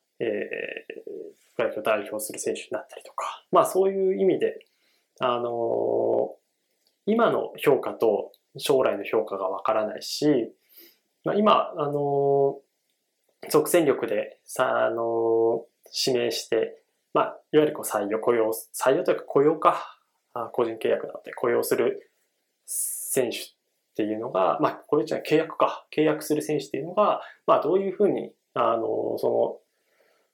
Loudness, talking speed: -25 LUFS, 280 characters per minute